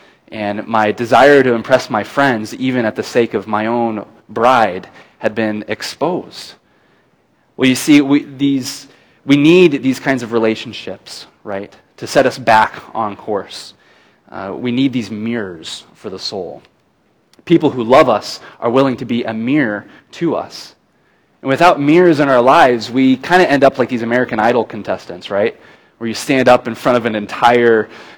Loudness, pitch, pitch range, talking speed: -14 LUFS, 125 Hz, 115-135 Hz, 175 wpm